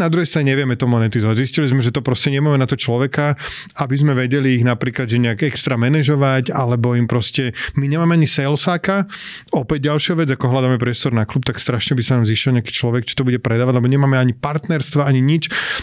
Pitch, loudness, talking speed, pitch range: 135 Hz, -17 LUFS, 215 wpm, 125-150 Hz